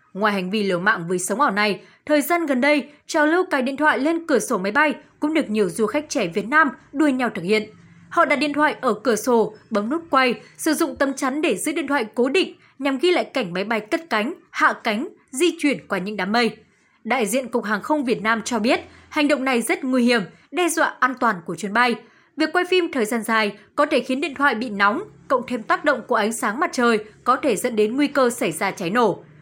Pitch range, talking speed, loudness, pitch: 220-300 Hz, 255 wpm, -21 LUFS, 255 Hz